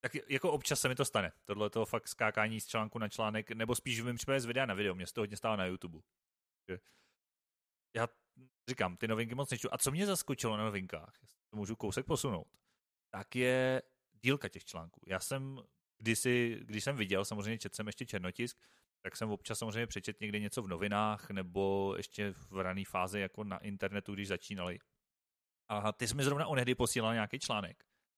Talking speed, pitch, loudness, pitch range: 190 wpm, 110 Hz, -37 LUFS, 100-125 Hz